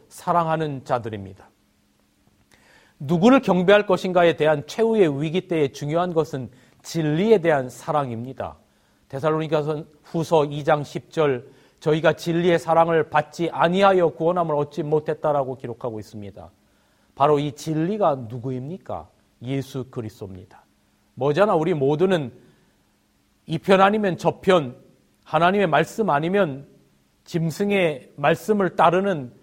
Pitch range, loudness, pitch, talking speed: 130-175 Hz, -21 LUFS, 155 Hz, 285 characters per minute